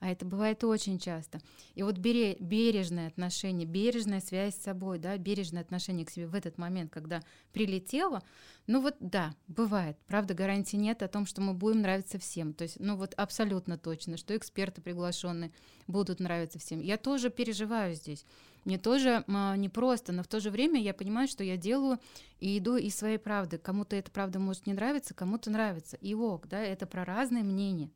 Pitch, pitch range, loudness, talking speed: 195 Hz, 180-215 Hz, -34 LUFS, 185 wpm